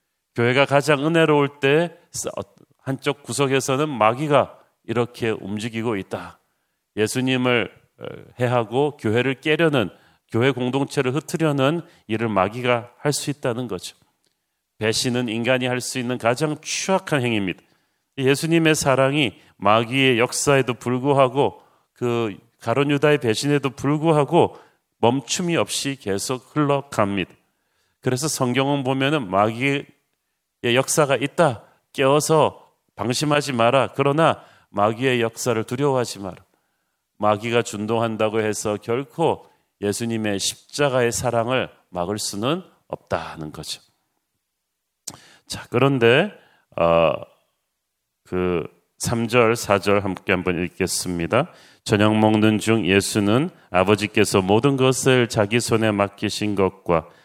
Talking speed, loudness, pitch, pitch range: 255 characters per minute, -21 LUFS, 120 Hz, 105-140 Hz